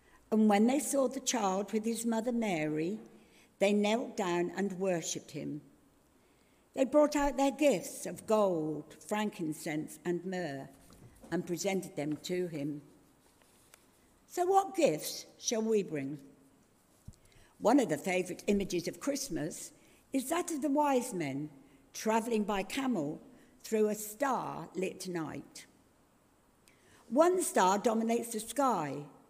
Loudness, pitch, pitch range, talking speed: -33 LUFS, 205 Hz, 170-255 Hz, 130 wpm